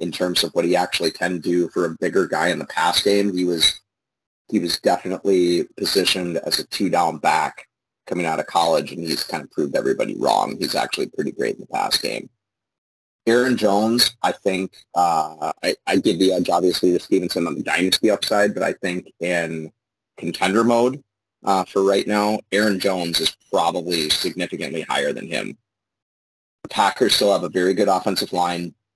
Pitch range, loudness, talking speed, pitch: 85-110 Hz, -20 LUFS, 180 wpm, 100 Hz